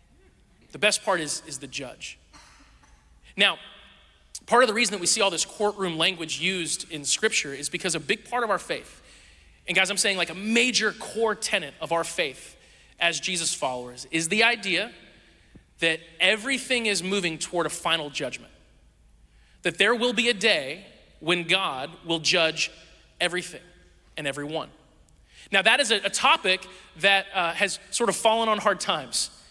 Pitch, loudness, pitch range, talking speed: 180 Hz, -24 LUFS, 160-210 Hz, 170 wpm